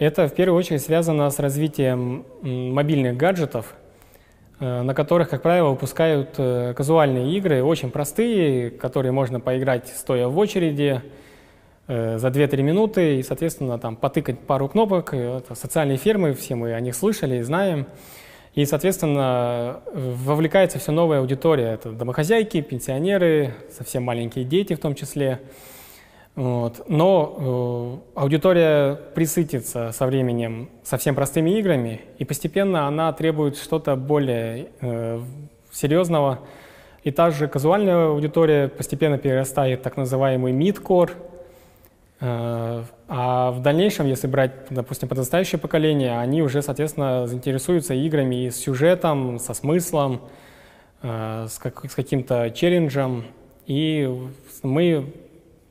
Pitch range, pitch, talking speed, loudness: 125-160 Hz, 140 Hz, 125 wpm, -22 LUFS